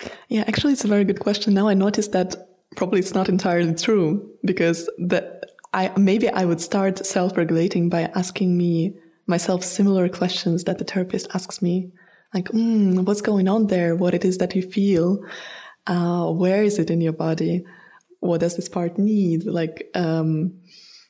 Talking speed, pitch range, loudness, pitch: 175 wpm, 175-200 Hz, -21 LUFS, 185 Hz